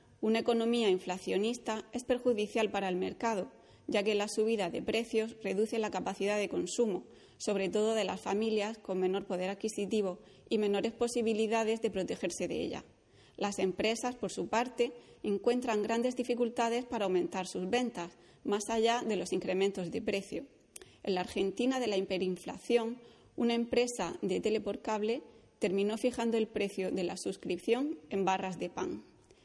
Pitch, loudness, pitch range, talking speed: 220 Hz, -34 LUFS, 195-235 Hz, 155 wpm